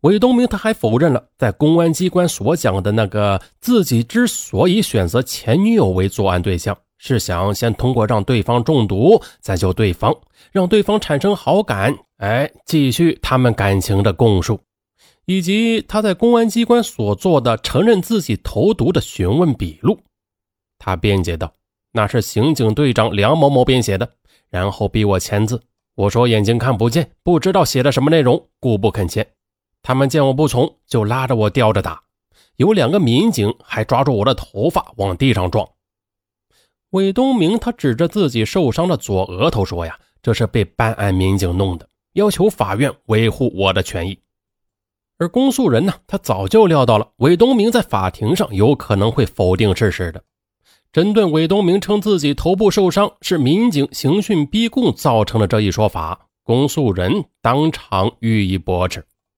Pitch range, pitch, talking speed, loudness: 100-165 Hz, 115 Hz, 255 characters per minute, -16 LUFS